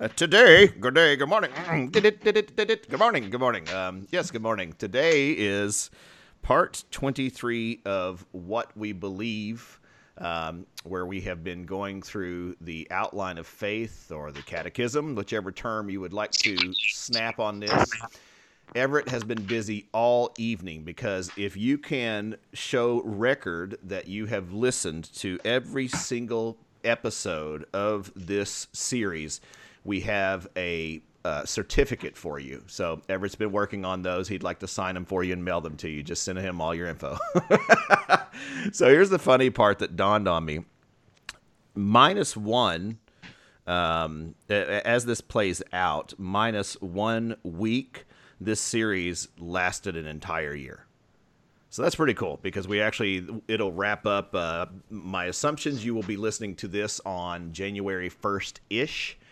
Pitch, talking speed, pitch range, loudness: 100 Hz, 150 wpm, 90-115 Hz, -26 LUFS